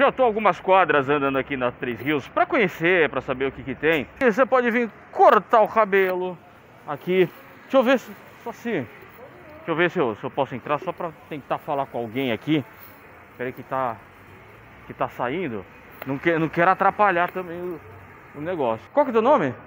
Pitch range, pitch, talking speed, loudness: 130-190 Hz, 150 Hz, 205 wpm, -22 LUFS